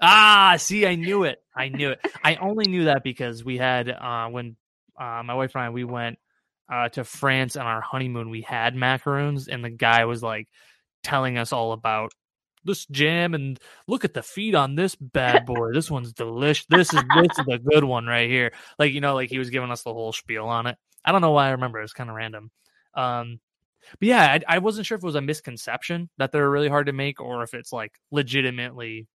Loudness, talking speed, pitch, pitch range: -22 LUFS, 230 wpm, 130 Hz, 120-150 Hz